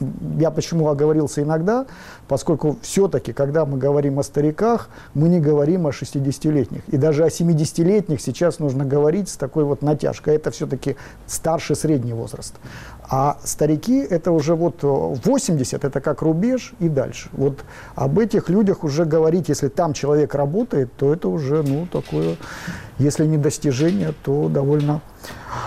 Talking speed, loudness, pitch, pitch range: 145 wpm, -20 LUFS, 150 Hz, 140-165 Hz